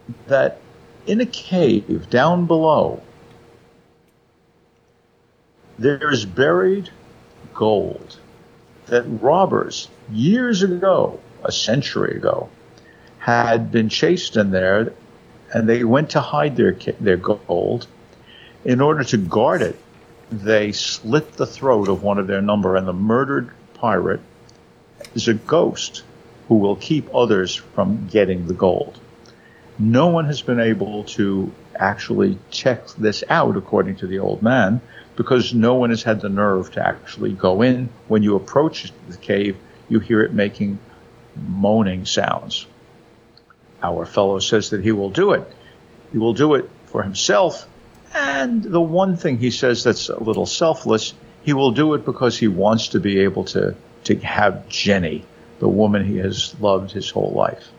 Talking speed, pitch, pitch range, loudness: 145 wpm, 115 Hz, 100-130 Hz, -19 LUFS